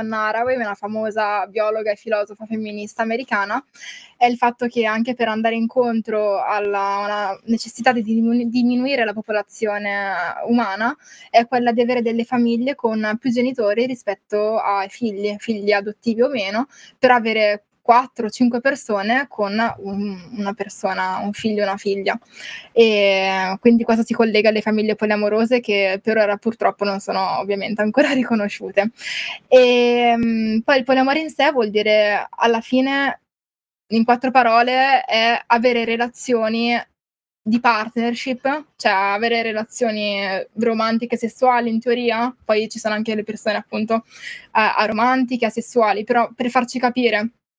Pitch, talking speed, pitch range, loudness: 225 Hz, 135 wpm, 210-240 Hz, -19 LUFS